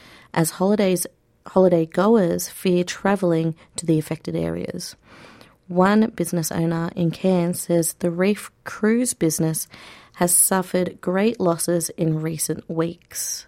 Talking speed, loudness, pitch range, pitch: 120 wpm, -21 LUFS, 165-185 Hz, 175 Hz